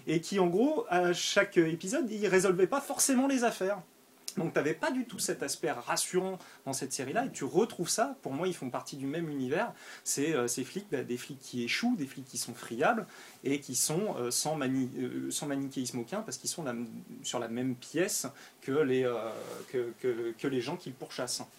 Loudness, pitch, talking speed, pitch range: -32 LUFS, 155 Hz, 225 wpm, 130-200 Hz